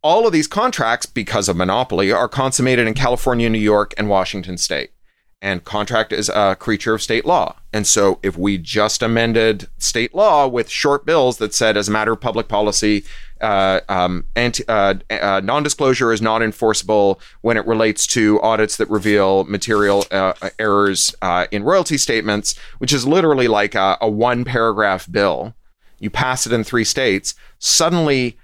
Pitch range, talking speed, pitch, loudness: 100-120 Hz, 175 wpm, 110 Hz, -17 LUFS